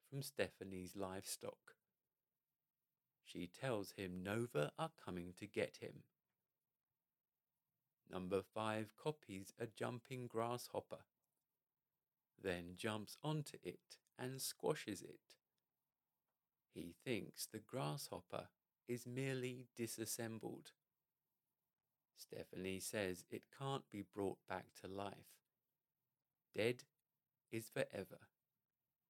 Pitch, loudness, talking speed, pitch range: 110 Hz, -48 LUFS, 90 wpm, 95-125 Hz